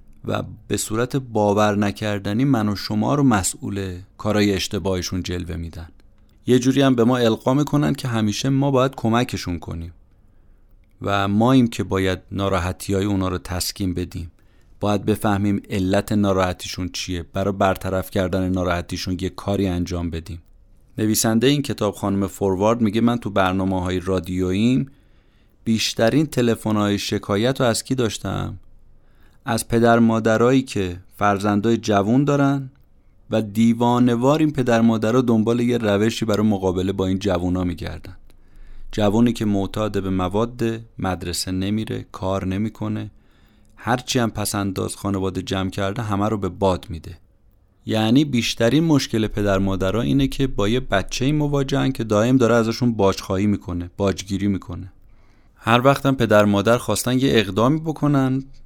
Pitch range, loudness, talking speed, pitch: 95-115 Hz, -20 LUFS, 145 wpm, 105 Hz